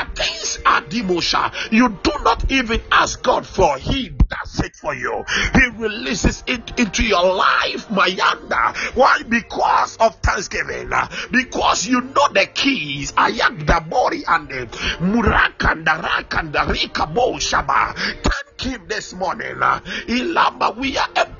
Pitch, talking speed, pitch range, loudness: 235 Hz, 130 wpm, 200-255 Hz, -18 LUFS